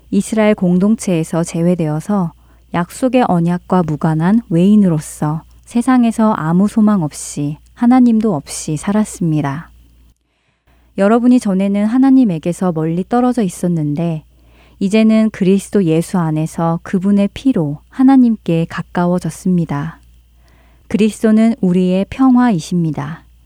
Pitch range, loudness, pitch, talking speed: 160-215 Hz, -14 LUFS, 180 Hz, 290 characters per minute